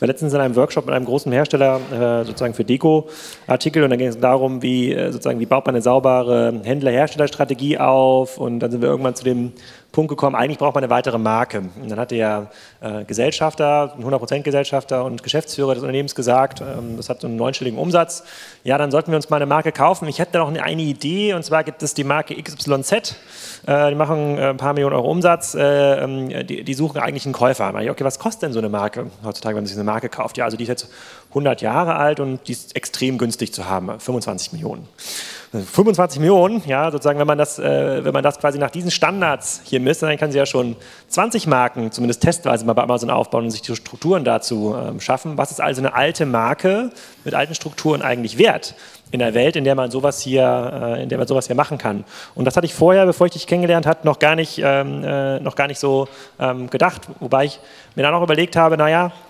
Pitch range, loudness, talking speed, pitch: 125-155 Hz, -18 LUFS, 225 wpm, 135 Hz